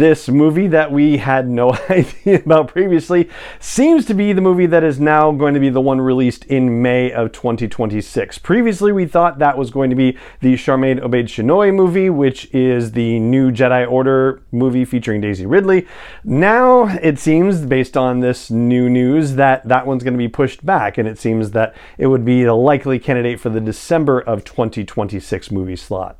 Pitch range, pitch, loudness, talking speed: 120-155 Hz, 130 Hz, -15 LUFS, 190 wpm